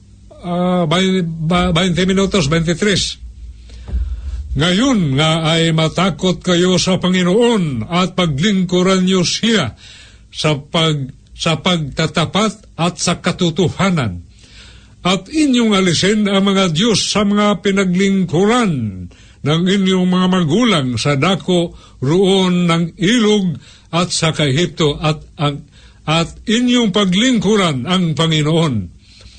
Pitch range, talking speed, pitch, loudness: 150-190 Hz, 100 wpm, 175 Hz, -15 LUFS